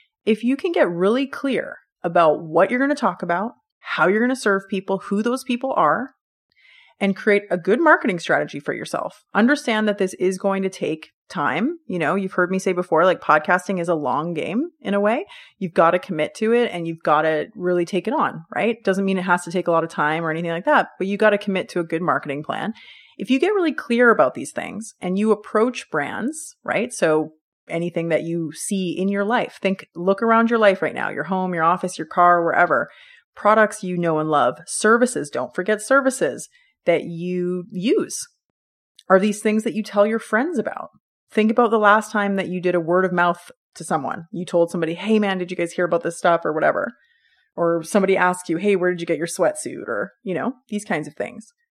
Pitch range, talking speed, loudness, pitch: 175-230 Hz, 225 wpm, -20 LUFS, 195 Hz